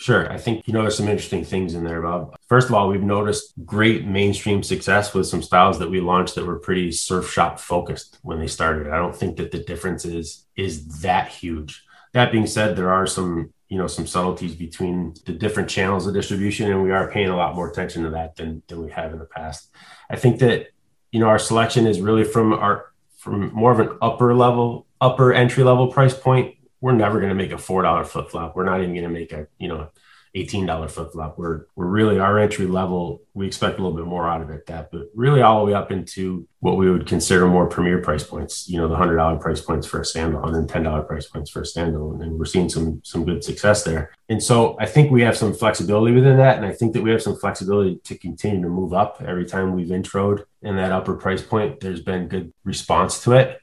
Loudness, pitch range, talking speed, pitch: -20 LUFS, 85-110 Hz, 245 wpm, 95 Hz